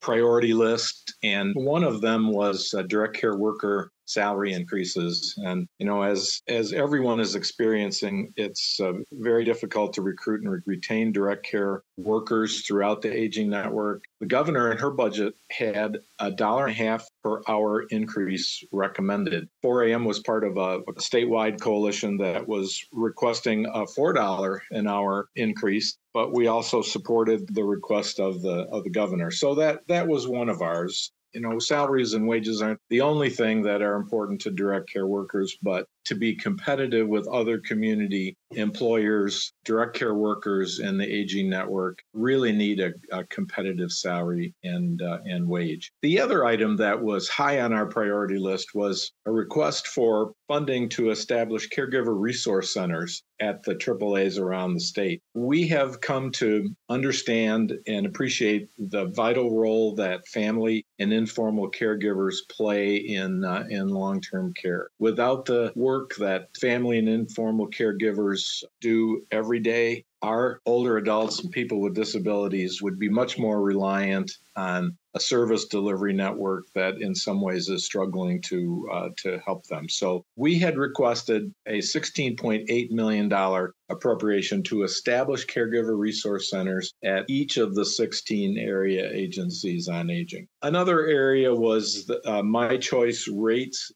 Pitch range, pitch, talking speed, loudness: 100-120 Hz, 110 Hz, 155 wpm, -26 LUFS